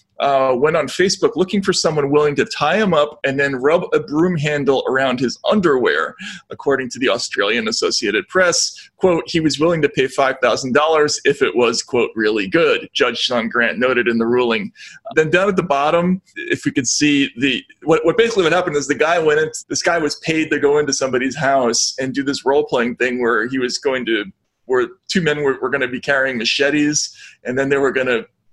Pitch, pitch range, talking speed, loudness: 145 Hz, 130-175 Hz, 215 wpm, -17 LUFS